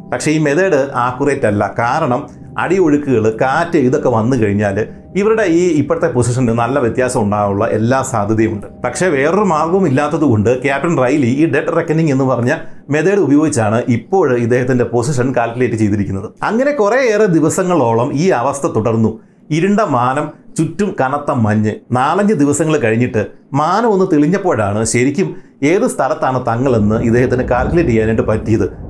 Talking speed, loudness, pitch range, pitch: 135 wpm, -14 LUFS, 115-160 Hz, 125 Hz